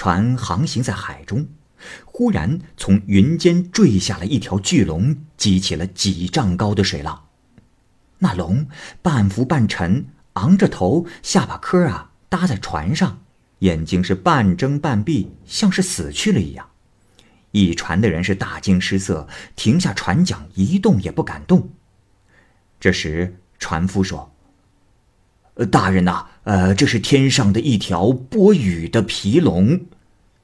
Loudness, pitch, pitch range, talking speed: -18 LUFS, 100 Hz, 95-145 Hz, 195 characters per minute